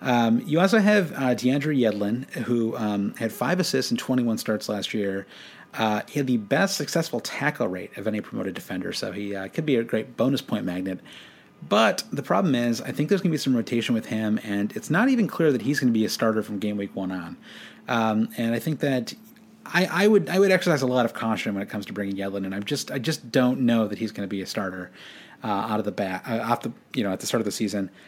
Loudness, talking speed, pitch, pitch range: -25 LUFS, 255 wpm, 120 Hz, 105-145 Hz